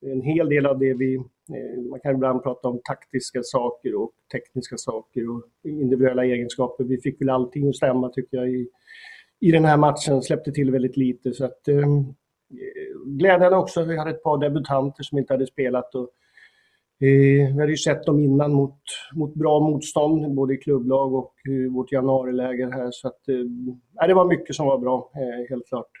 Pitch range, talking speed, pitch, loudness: 130-150 Hz, 185 wpm, 135 Hz, -22 LUFS